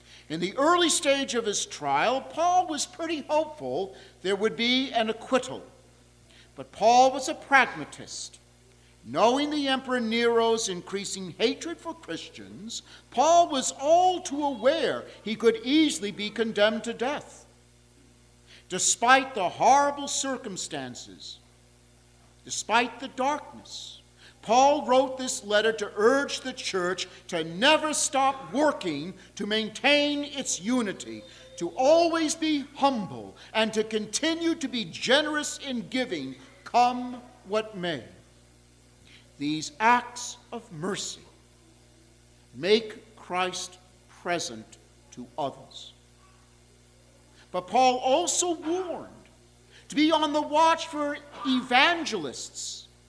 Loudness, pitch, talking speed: -26 LUFS, 225 Hz, 110 wpm